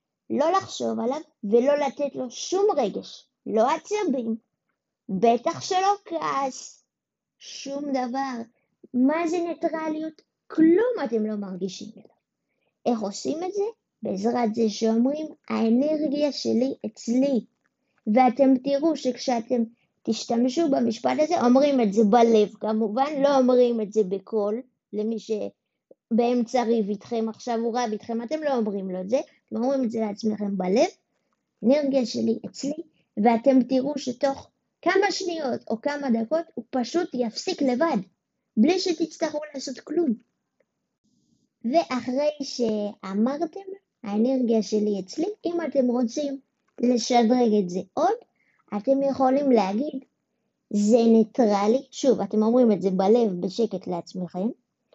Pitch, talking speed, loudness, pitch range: 250 Hz, 125 wpm, -24 LUFS, 225-290 Hz